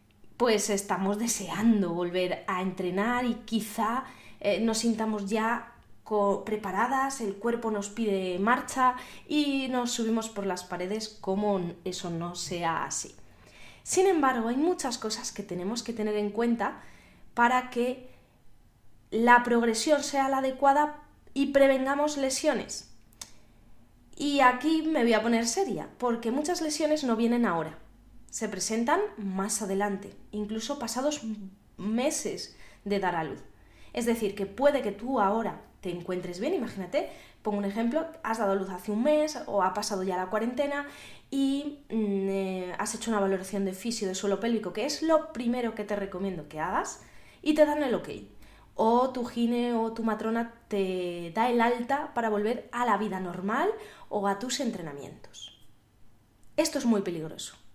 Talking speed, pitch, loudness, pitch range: 160 wpm, 220 Hz, -29 LUFS, 195-250 Hz